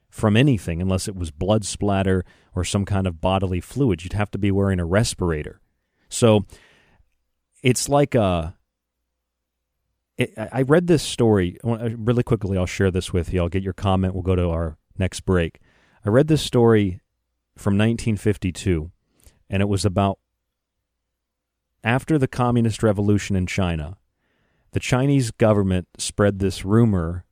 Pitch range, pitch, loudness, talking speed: 85-110 Hz, 95 Hz, -21 LUFS, 150 wpm